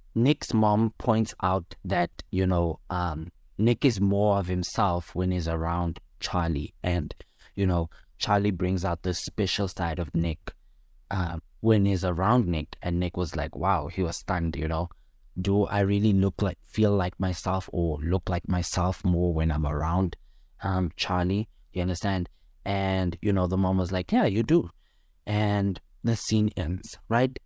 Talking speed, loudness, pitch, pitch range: 170 wpm, -27 LUFS, 90 Hz, 85-100 Hz